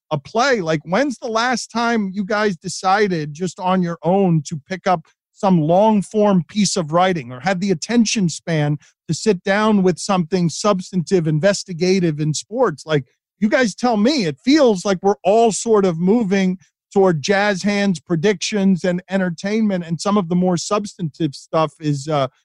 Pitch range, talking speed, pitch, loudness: 170-210 Hz, 175 wpm, 190 Hz, -18 LUFS